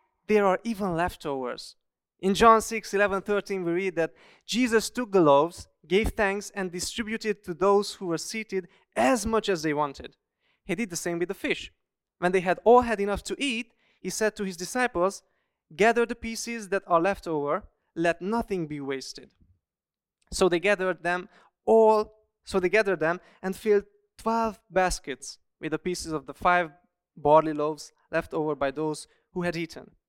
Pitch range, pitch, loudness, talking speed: 170-215 Hz, 190 Hz, -26 LUFS, 175 wpm